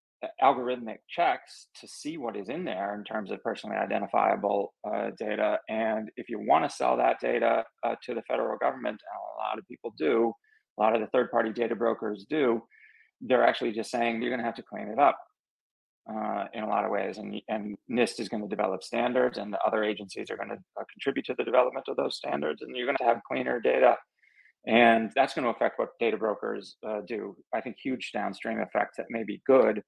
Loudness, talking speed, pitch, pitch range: -29 LUFS, 220 wpm, 115 Hz, 110-120 Hz